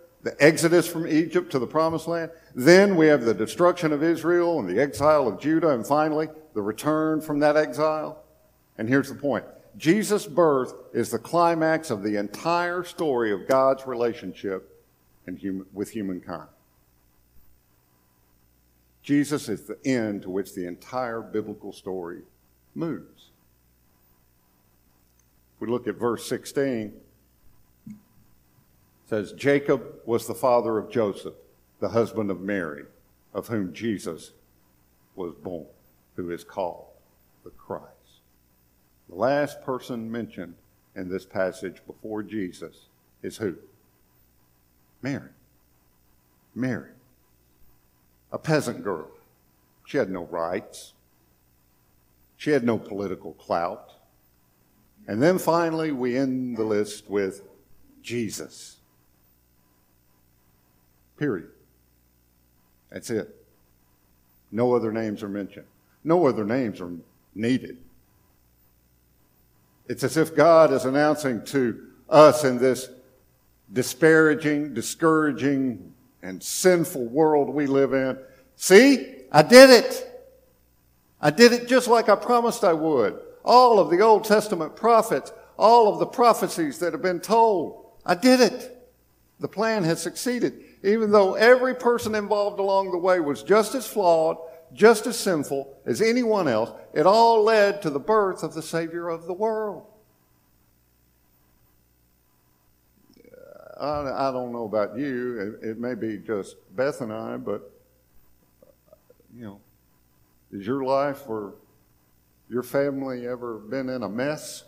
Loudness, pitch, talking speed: -23 LUFS, 120 Hz, 125 wpm